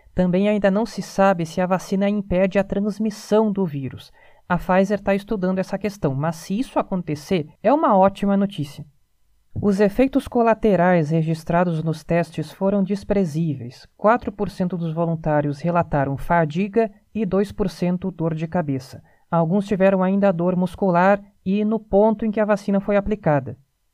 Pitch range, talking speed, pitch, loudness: 165-205 Hz, 150 wpm, 190 Hz, -21 LUFS